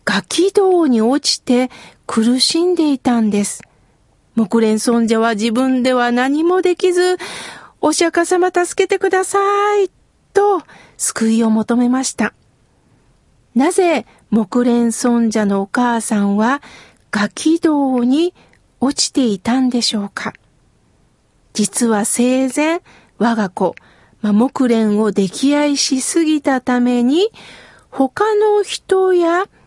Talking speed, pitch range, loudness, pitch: 200 characters per minute, 230-340 Hz, -15 LUFS, 260 Hz